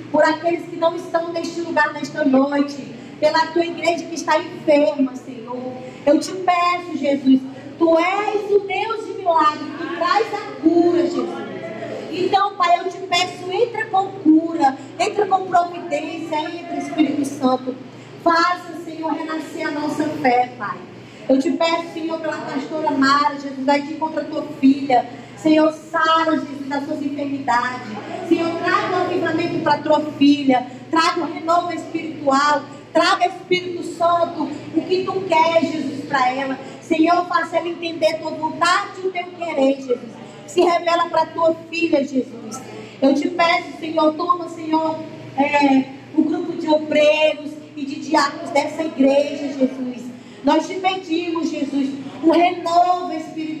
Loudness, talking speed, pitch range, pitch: -19 LUFS, 155 wpm, 285-340 Hz, 315 Hz